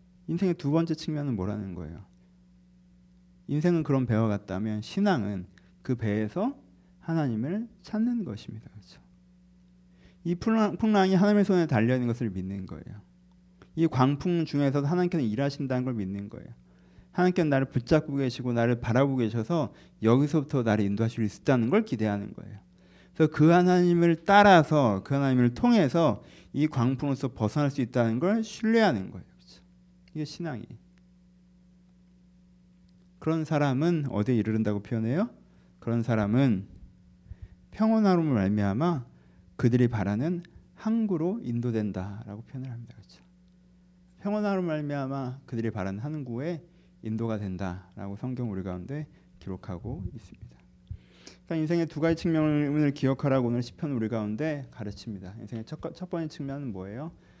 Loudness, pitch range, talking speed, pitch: -27 LUFS, 105-170 Hz, 325 characters per minute, 130 Hz